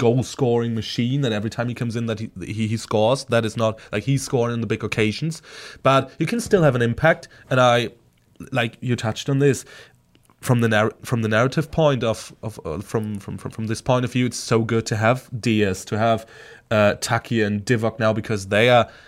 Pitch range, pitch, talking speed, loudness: 110-125 Hz, 115 Hz, 225 wpm, -21 LUFS